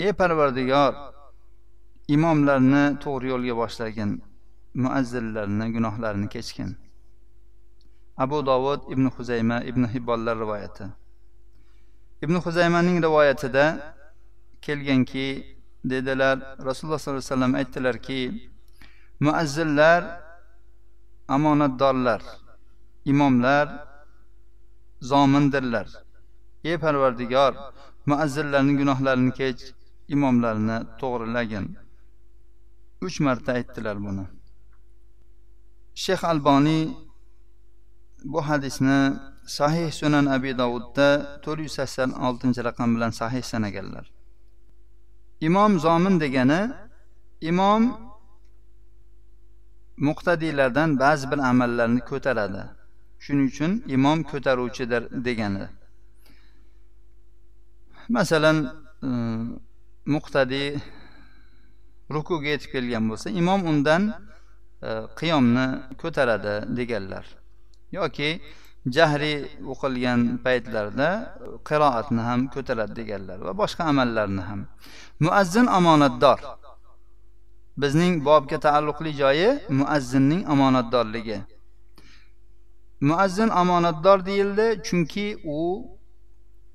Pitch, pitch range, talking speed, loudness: 130 Hz, 115-145 Hz, 75 wpm, -23 LUFS